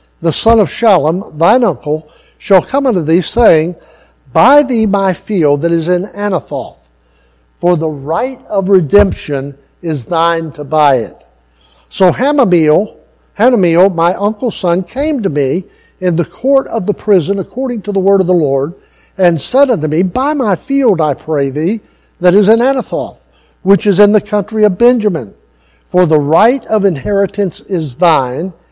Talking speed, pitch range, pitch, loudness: 165 wpm, 155-210 Hz, 180 Hz, -12 LUFS